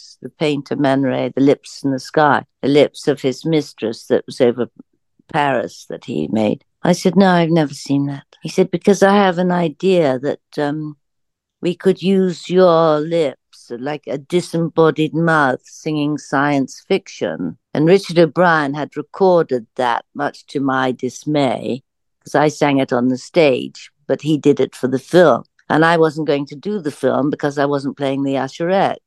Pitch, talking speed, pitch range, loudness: 150 Hz, 180 wpm, 135-170 Hz, -17 LUFS